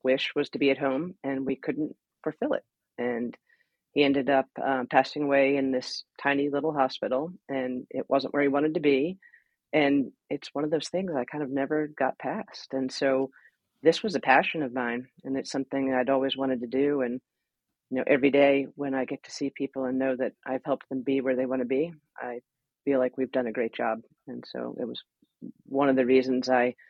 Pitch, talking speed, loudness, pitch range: 135 Hz, 220 wpm, -28 LUFS, 130-140 Hz